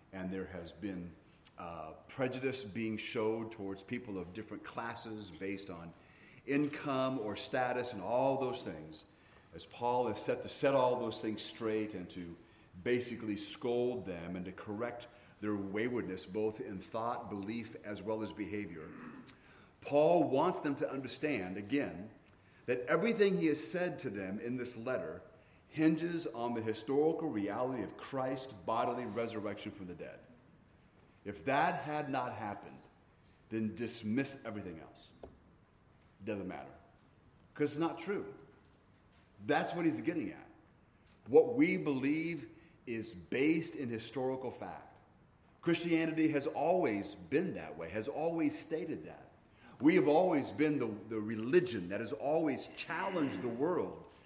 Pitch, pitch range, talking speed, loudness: 115 Hz, 105-145 Hz, 145 wpm, -36 LUFS